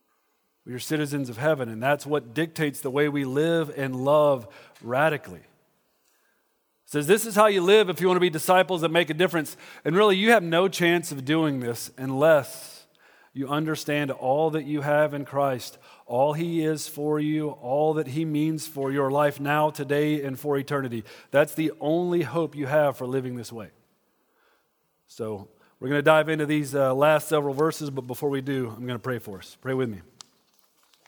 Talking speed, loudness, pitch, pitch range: 195 wpm, -24 LUFS, 150 Hz, 135-160 Hz